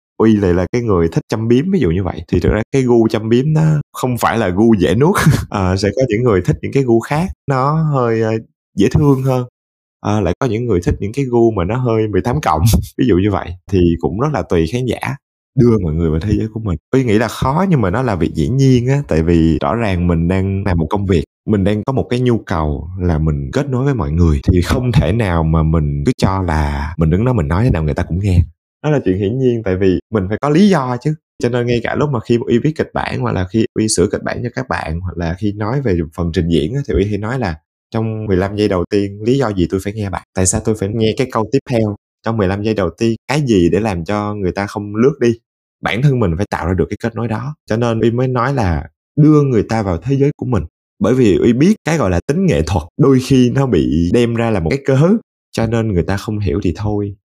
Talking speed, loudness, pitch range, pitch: 280 wpm, -15 LUFS, 90-125 Hz, 110 Hz